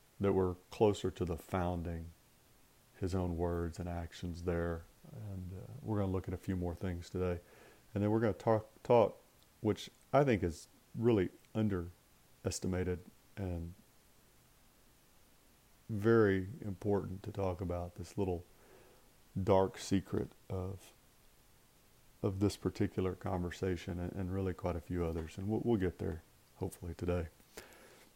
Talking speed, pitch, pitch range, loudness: 135 wpm, 95 Hz, 90-105 Hz, -37 LUFS